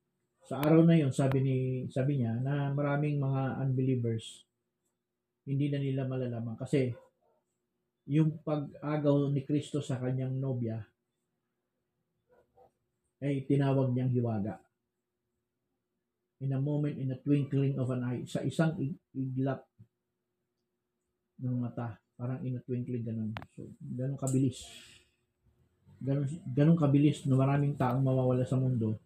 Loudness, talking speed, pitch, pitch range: -31 LUFS, 130 wpm, 130 Hz, 125-140 Hz